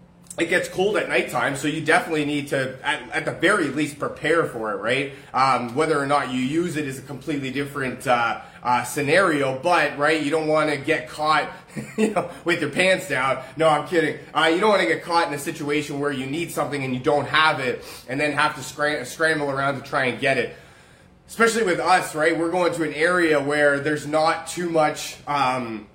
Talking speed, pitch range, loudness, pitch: 220 wpm, 140-165 Hz, -22 LUFS, 150 Hz